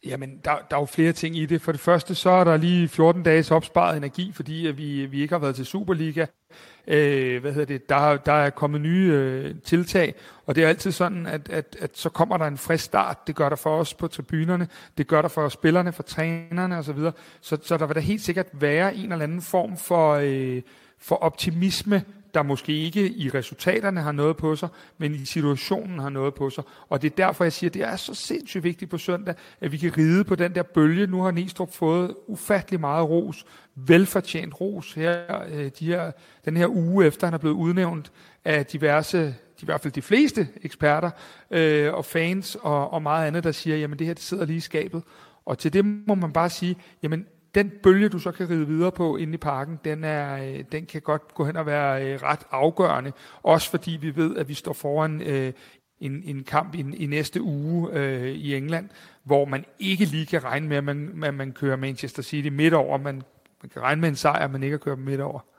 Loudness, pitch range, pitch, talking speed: -24 LUFS, 145-175 Hz, 160 Hz, 220 wpm